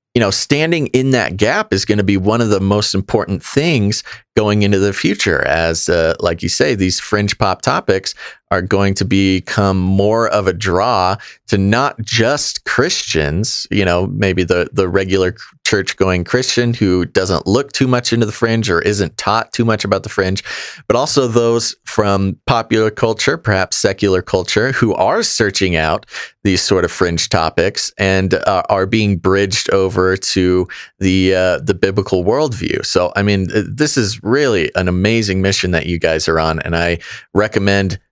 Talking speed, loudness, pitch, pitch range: 180 wpm, -15 LUFS, 100 Hz, 95-110 Hz